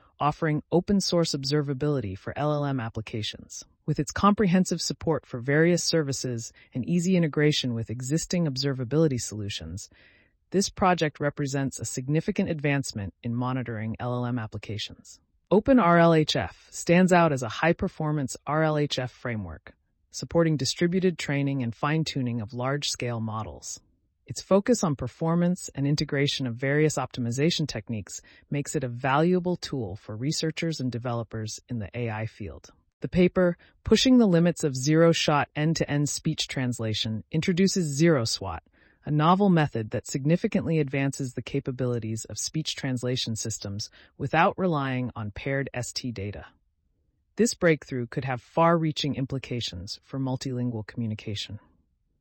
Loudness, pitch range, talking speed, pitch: -26 LUFS, 115-160 Hz, 130 wpm, 140 Hz